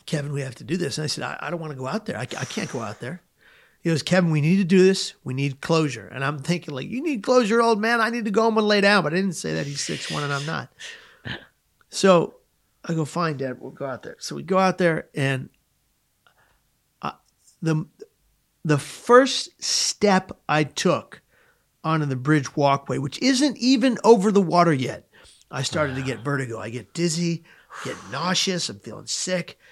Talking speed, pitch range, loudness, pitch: 215 wpm, 140-205 Hz, -23 LUFS, 165 Hz